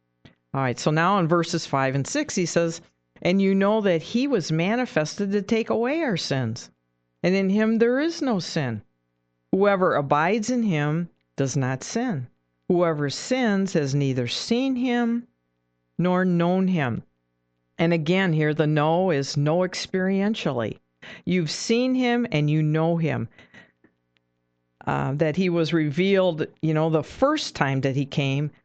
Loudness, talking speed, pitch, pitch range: -23 LUFS, 155 wpm, 165 Hz, 135-195 Hz